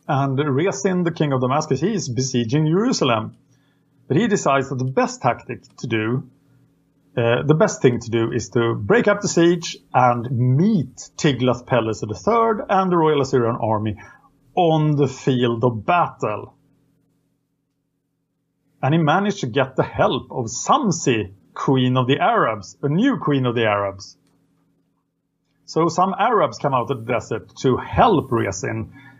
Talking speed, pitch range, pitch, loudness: 155 wpm, 120-155 Hz, 140 Hz, -20 LUFS